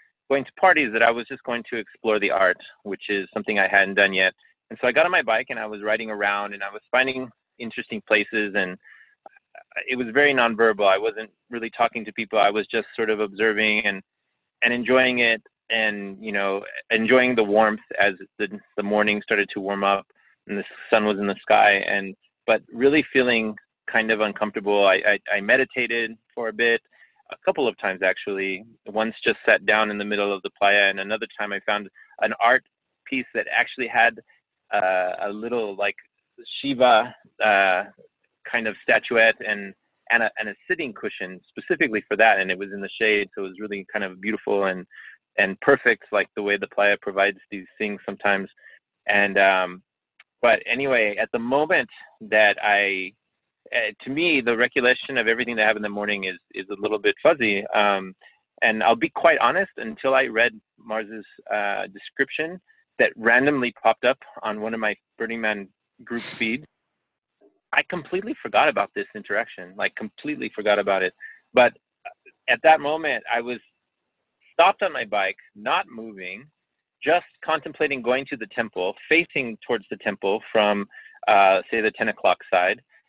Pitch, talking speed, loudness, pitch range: 110 Hz, 185 wpm, -22 LUFS, 100-125 Hz